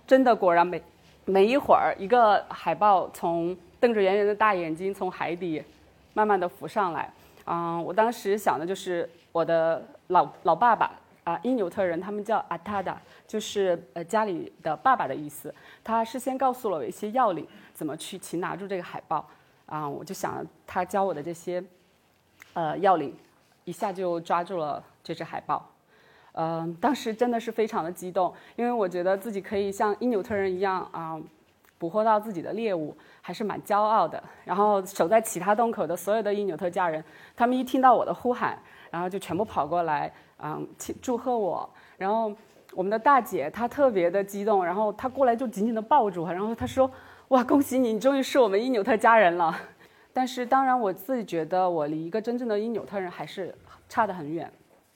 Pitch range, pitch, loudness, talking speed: 175-230 Hz, 200 Hz, -26 LUFS, 290 characters per minute